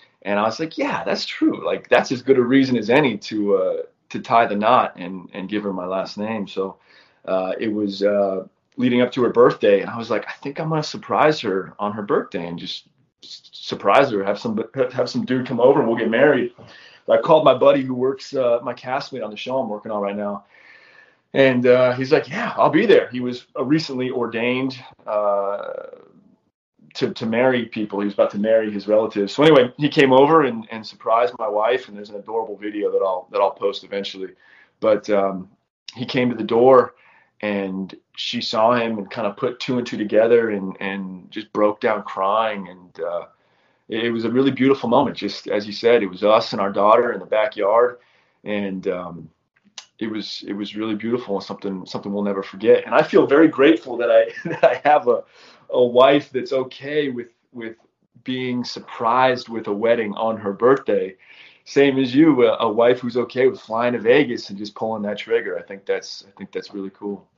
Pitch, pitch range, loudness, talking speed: 115 Hz, 100-130 Hz, -19 LUFS, 215 wpm